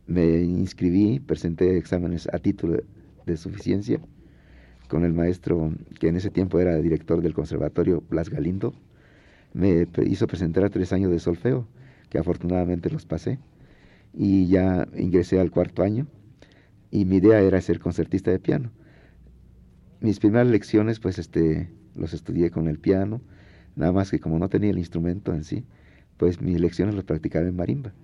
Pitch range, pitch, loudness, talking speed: 85-100 Hz, 90 Hz, -24 LUFS, 160 wpm